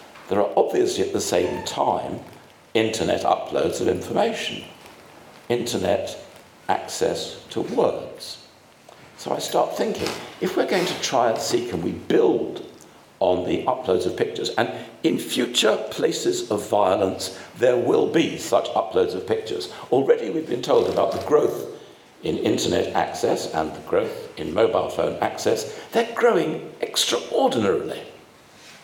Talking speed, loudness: 140 wpm, -23 LUFS